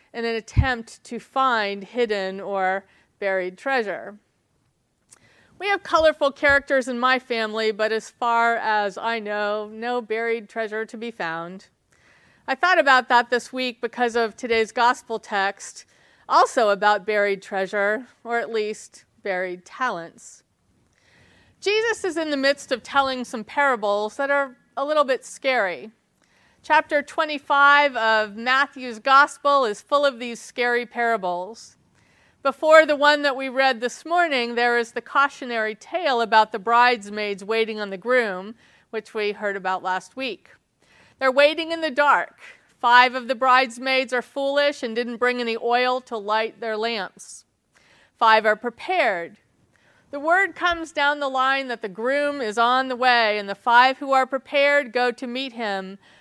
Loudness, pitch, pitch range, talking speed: -21 LUFS, 240 Hz, 220-275 Hz, 155 wpm